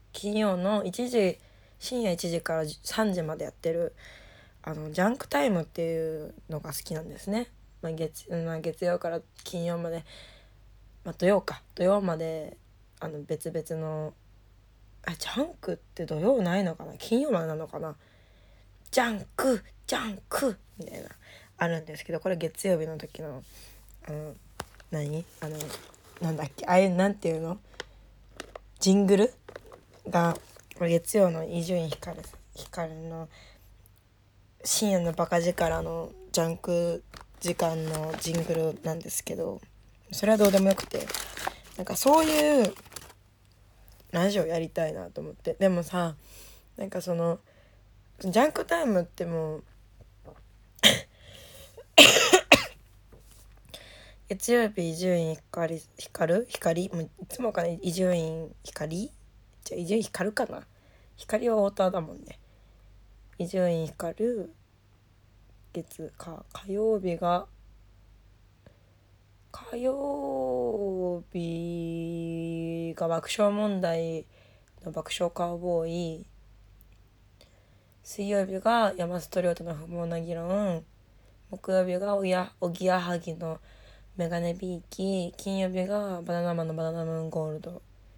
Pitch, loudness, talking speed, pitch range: 165 Hz, -28 LUFS, 225 characters per minute, 140-185 Hz